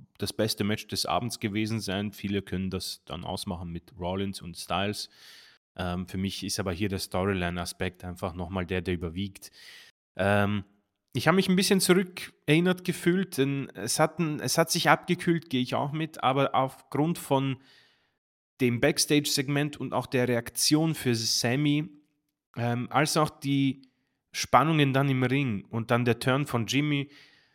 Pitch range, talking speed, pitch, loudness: 100-145 Hz, 160 wpm, 125 Hz, -28 LUFS